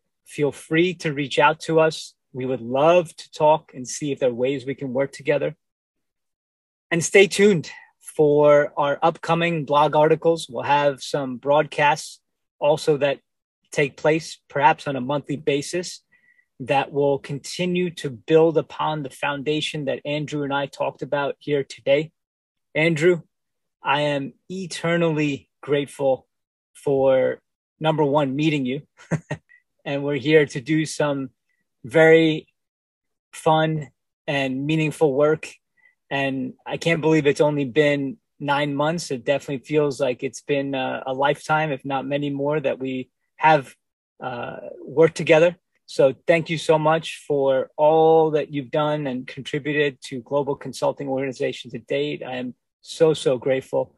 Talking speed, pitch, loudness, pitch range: 145 wpm, 145 Hz, -21 LUFS, 140-160 Hz